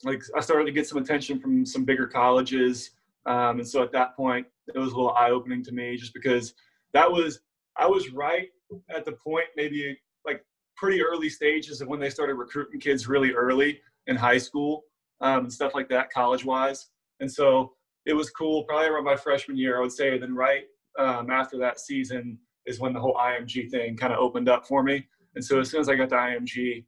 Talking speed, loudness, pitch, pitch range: 215 wpm, -26 LUFS, 130 Hz, 125-145 Hz